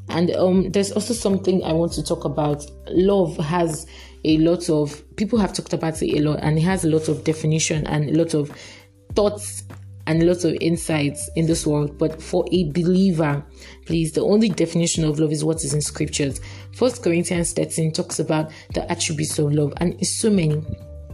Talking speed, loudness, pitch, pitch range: 200 wpm, -21 LUFS, 160 Hz, 150-175 Hz